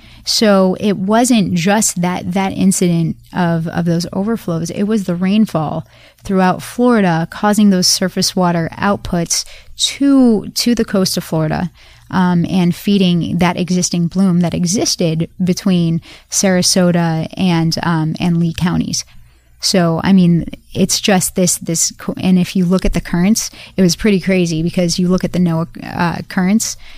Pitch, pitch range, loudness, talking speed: 180 Hz, 170-195 Hz, -14 LUFS, 155 wpm